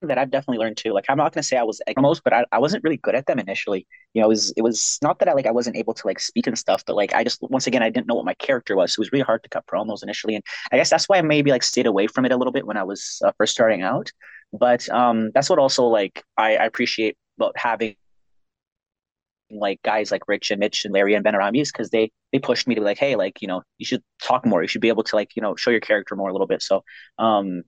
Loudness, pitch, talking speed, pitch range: -21 LUFS, 110 Hz, 305 wpm, 100-125 Hz